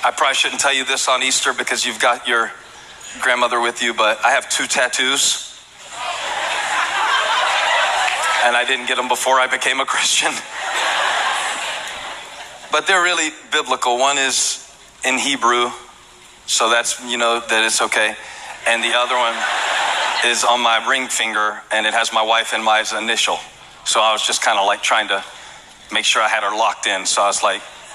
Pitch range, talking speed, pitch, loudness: 115-130 Hz, 175 wpm, 120 Hz, -17 LUFS